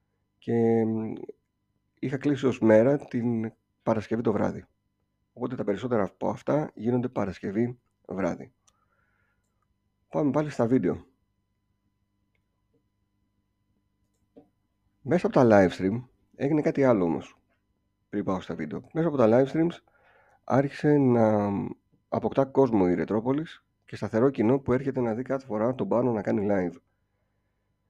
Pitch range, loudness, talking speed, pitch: 100-125 Hz, -26 LUFS, 125 wpm, 105 Hz